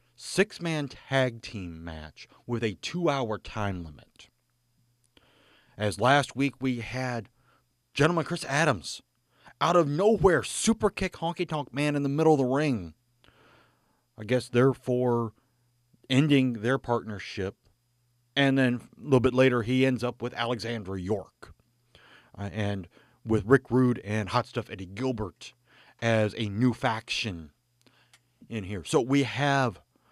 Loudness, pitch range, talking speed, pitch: -27 LUFS, 110-135 Hz, 135 wpm, 120 Hz